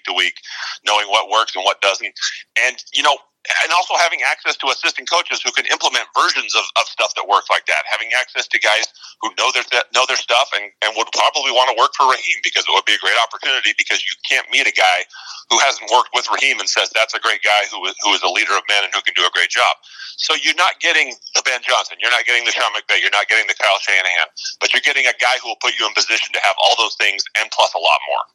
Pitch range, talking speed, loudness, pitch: 105-155 Hz, 270 wpm, -15 LUFS, 115 Hz